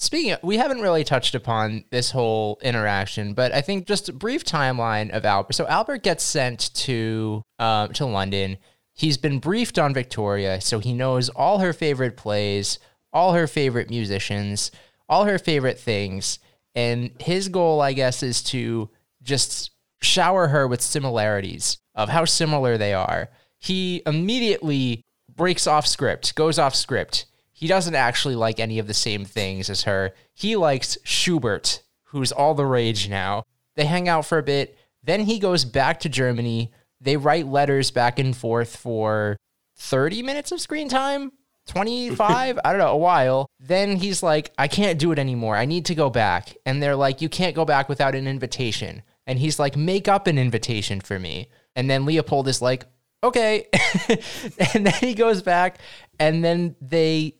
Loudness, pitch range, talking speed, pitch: -22 LUFS, 115-170 Hz, 175 wpm, 135 Hz